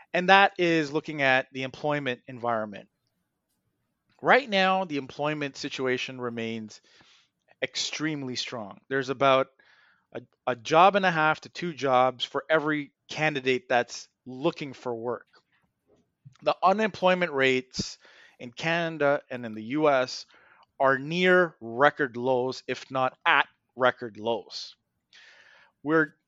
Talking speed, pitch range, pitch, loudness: 120 wpm, 125-155 Hz, 135 Hz, -26 LUFS